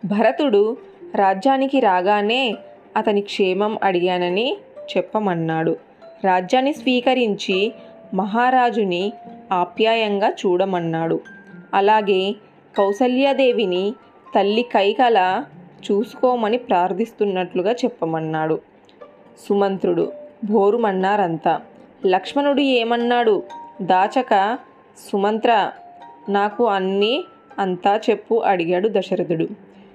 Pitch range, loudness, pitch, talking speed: 190-245 Hz, -19 LUFS, 210 Hz, 60 wpm